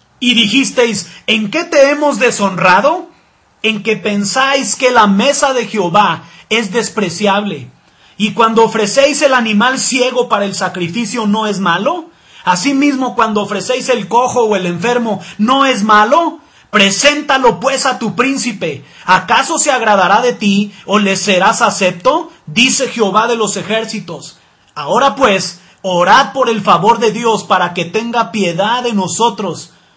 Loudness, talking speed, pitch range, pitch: -12 LUFS, 145 wpm, 200-255 Hz, 220 Hz